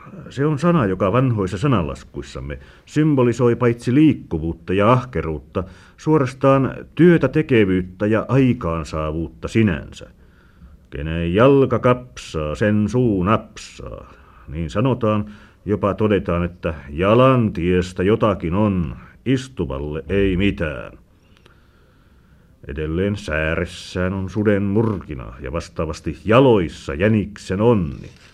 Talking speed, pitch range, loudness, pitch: 95 wpm, 85-120 Hz, -19 LUFS, 100 Hz